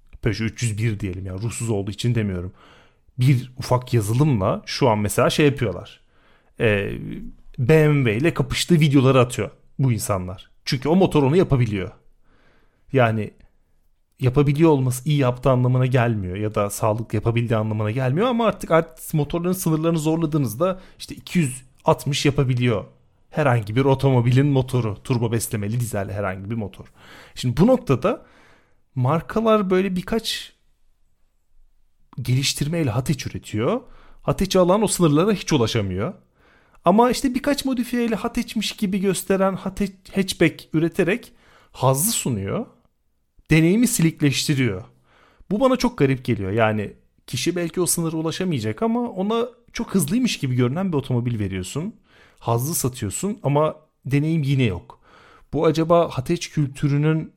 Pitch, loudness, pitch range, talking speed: 140 Hz, -21 LUFS, 115-170 Hz, 125 wpm